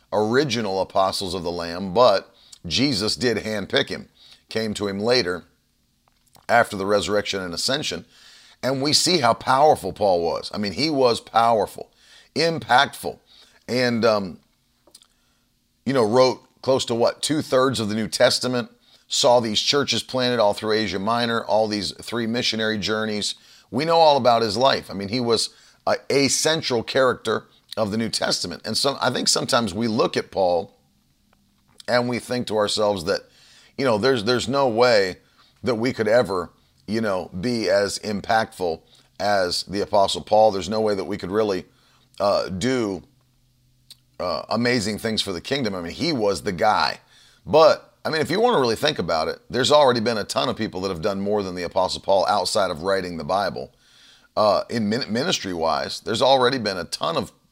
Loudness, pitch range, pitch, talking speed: -21 LUFS, 100-125 Hz, 110 Hz, 180 wpm